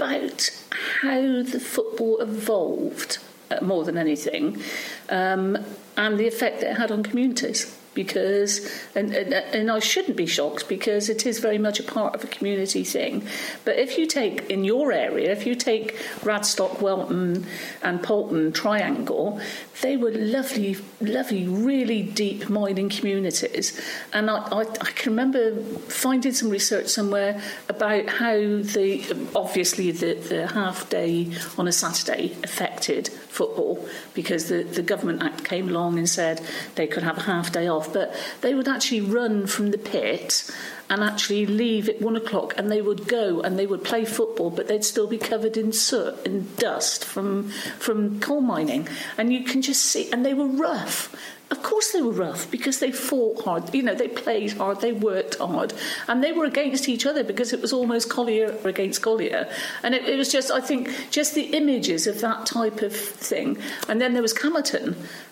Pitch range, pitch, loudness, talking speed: 200-250 Hz, 220 Hz, -24 LUFS, 175 wpm